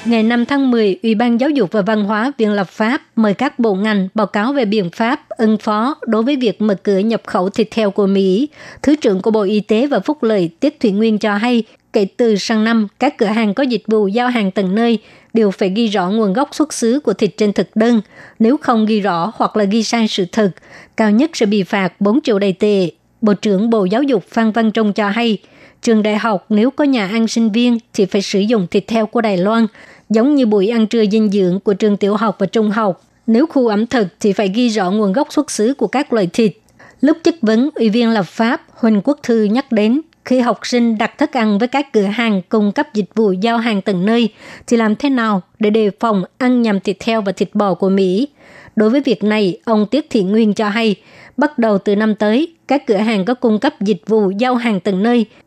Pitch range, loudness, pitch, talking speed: 210-235 Hz, -15 LUFS, 220 Hz, 245 wpm